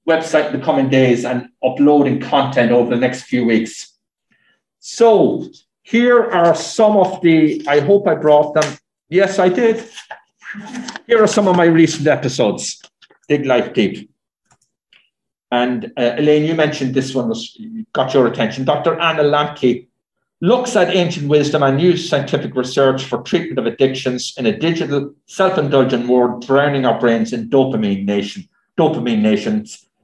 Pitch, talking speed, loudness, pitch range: 150 Hz, 150 wpm, -15 LUFS, 125-180 Hz